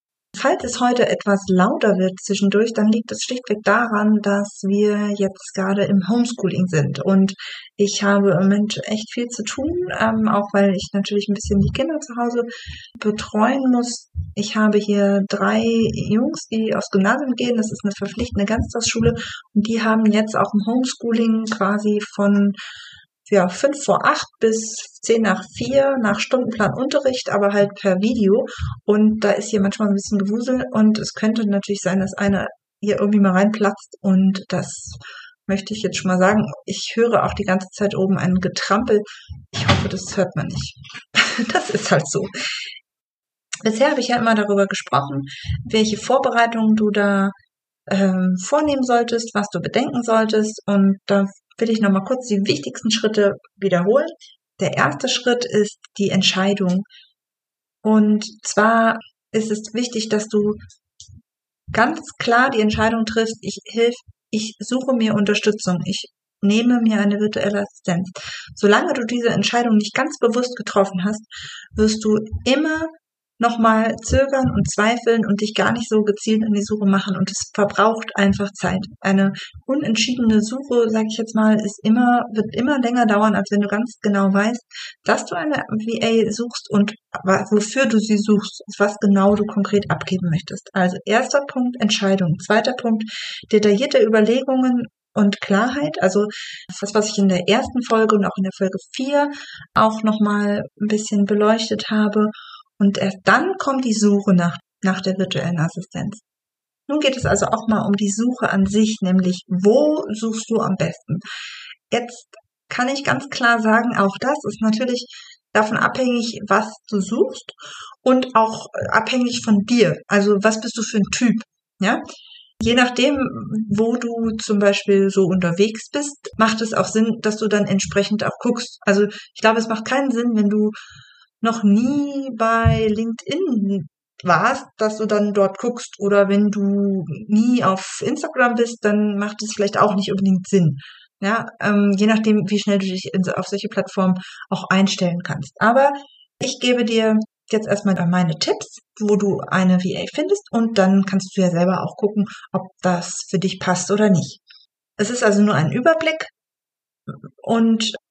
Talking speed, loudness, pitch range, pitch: 165 wpm, -19 LUFS, 200-230 Hz, 210 Hz